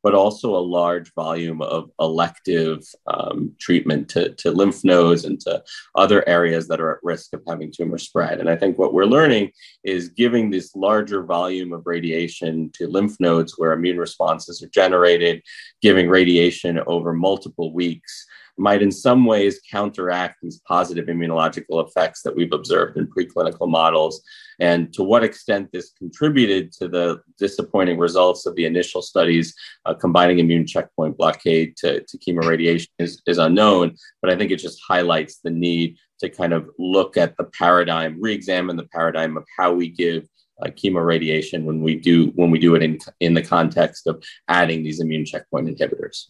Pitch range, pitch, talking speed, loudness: 85-90 Hz, 85 Hz, 170 wpm, -19 LUFS